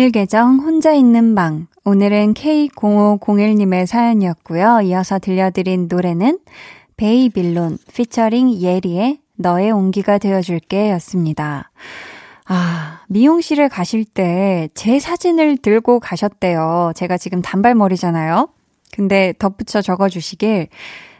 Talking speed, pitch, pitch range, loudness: 260 characters per minute, 200 Hz, 180-230 Hz, -15 LUFS